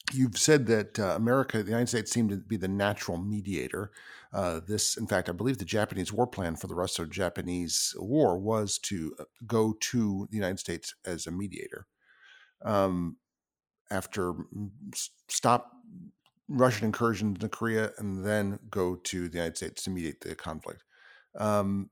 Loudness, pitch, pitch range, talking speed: -30 LUFS, 105 Hz, 95-115 Hz, 160 wpm